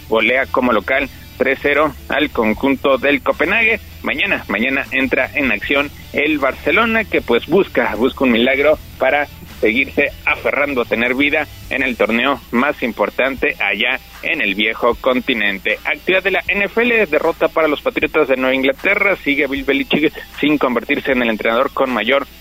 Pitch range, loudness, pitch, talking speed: 130-160 Hz, -16 LUFS, 140 Hz, 155 wpm